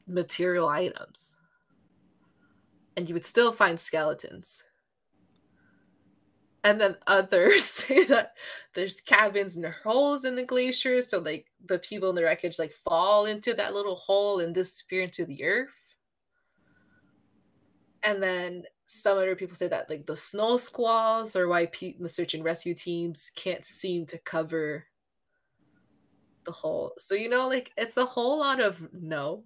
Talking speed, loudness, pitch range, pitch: 150 wpm, -27 LUFS, 170-225 Hz, 185 Hz